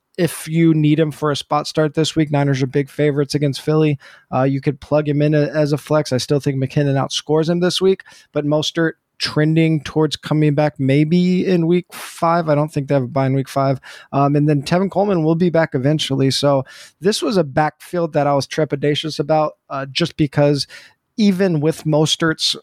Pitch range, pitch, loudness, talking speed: 145-160 Hz, 150 Hz, -18 LUFS, 210 wpm